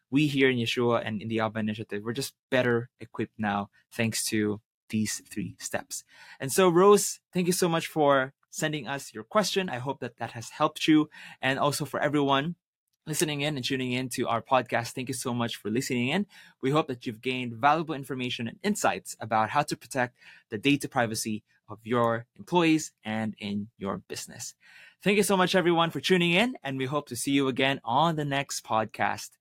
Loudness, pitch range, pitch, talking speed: -28 LUFS, 115-155 Hz, 135 Hz, 200 wpm